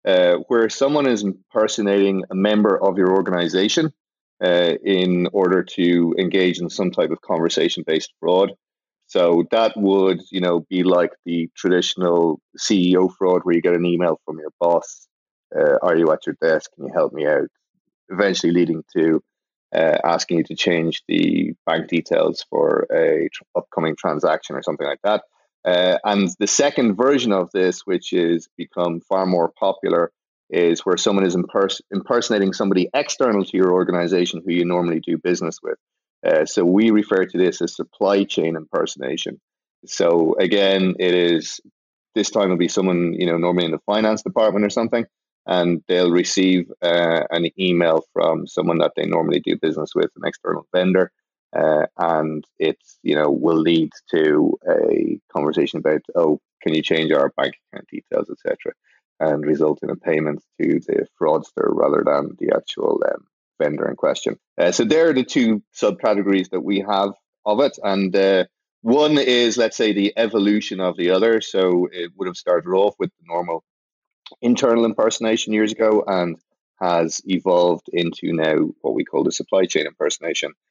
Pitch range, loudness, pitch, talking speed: 85-115 Hz, -19 LUFS, 95 Hz, 170 wpm